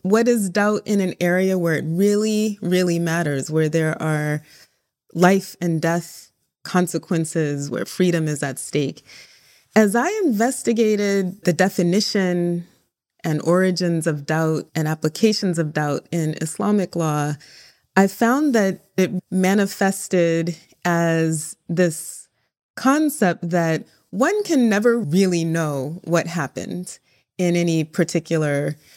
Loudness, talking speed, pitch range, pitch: -20 LUFS, 120 wpm, 160-195 Hz, 175 Hz